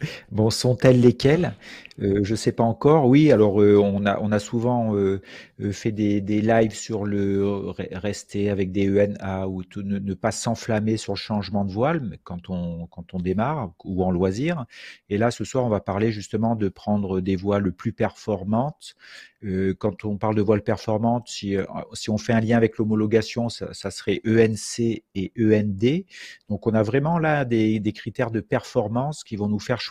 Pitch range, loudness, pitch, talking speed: 100-115 Hz, -23 LUFS, 105 Hz, 200 wpm